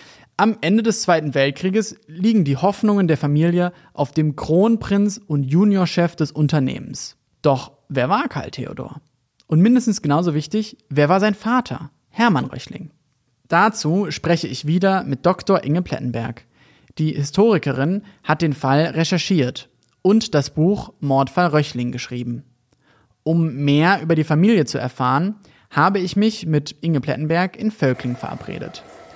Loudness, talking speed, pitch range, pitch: -19 LUFS, 140 wpm, 140-195 Hz, 160 Hz